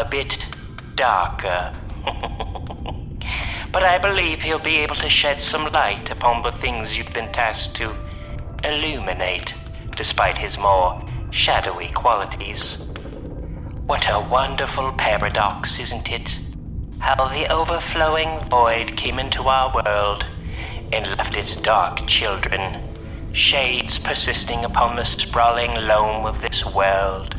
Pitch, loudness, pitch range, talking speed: 110 Hz, -20 LUFS, 95-130 Hz, 120 wpm